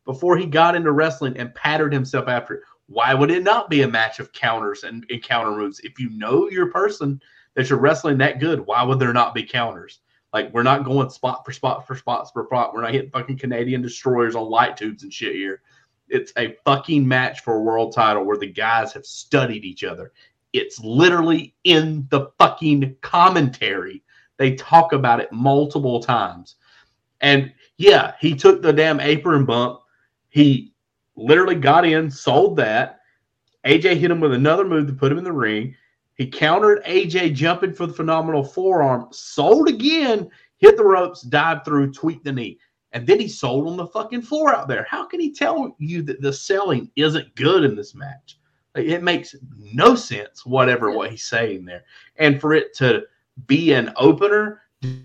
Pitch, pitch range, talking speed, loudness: 145 Hz, 130-175 Hz, 185 wpm, -18 LUFS